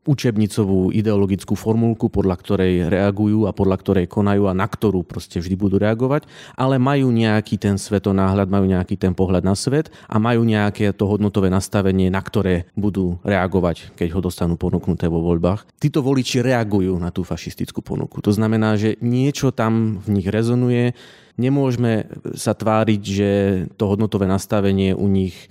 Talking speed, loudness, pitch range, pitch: 160 wpm, -19 LUFS, 95-115 Hz, 105 Hz